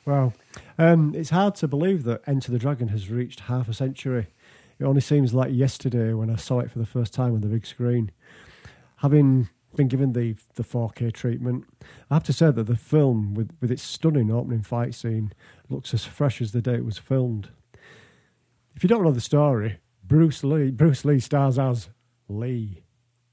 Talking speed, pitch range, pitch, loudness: 195 wpm, 115-140 Hz, 125 Hz, -24 LUFS